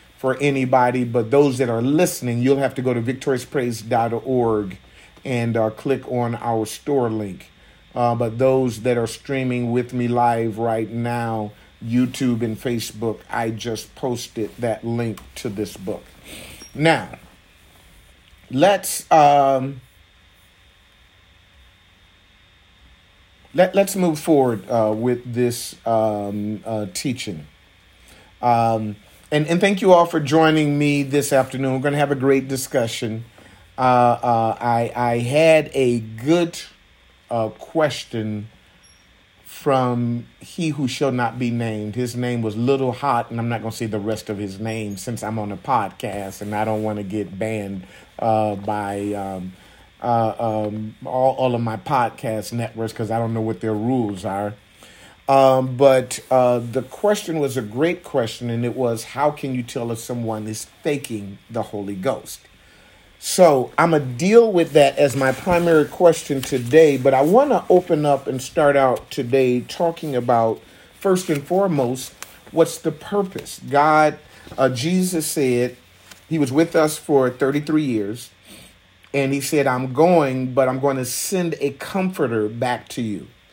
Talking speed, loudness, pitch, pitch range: 155 wpm, -20 LUFS, 120 Hz, 110-140 Hz